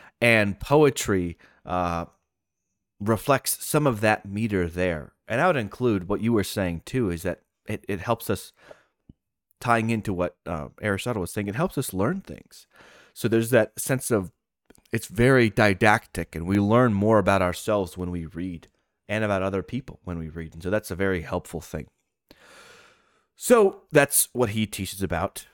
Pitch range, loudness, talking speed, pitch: 90-115 Hz, -24 LUFS, 170 wpm, 100 Hz